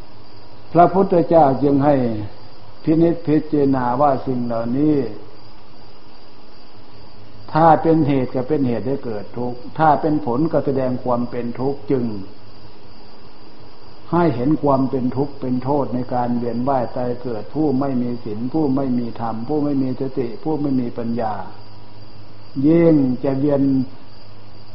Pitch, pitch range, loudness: 125 Hz, 105-140 Hz, -19 LUFS